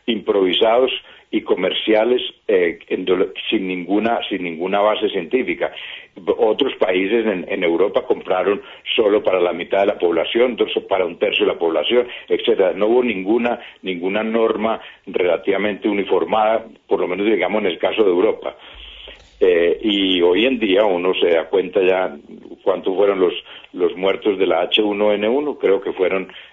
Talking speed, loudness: 150 wpm, -18 LUFS